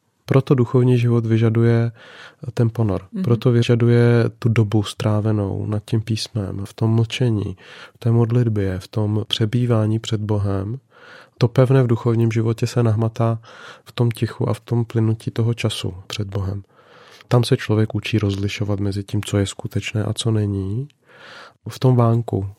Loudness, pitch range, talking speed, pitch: -20 LUFS, 105-120 Hz, 155 wpm, 115 Hz